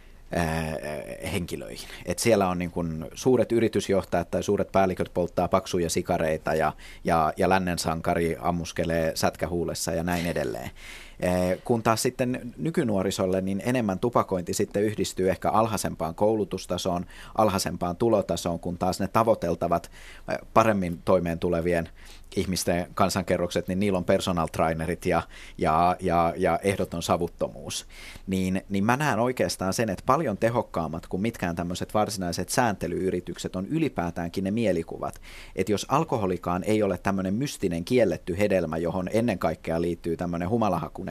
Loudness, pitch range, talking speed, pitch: -26 LUFS, 85-100 Hz, 135 wpm, 90 Hz